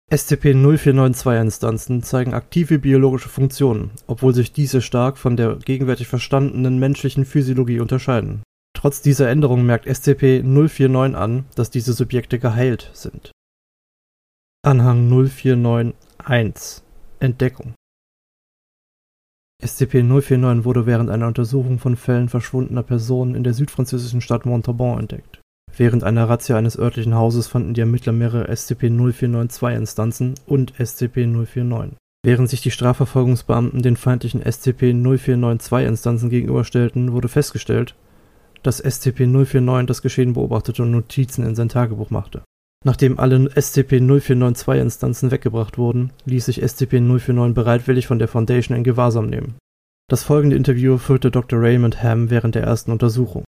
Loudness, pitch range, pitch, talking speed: -18 LUFS, 120-130 Hz, 125 Hz, 120 wpm